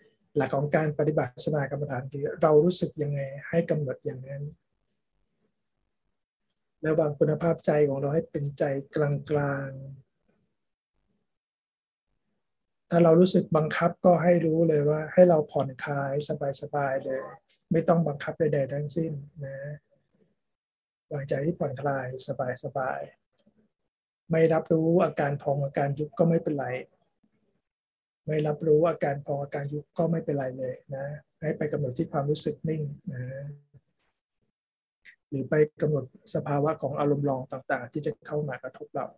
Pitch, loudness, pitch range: 150 Hz, -27 LUFS, 140-160 Hz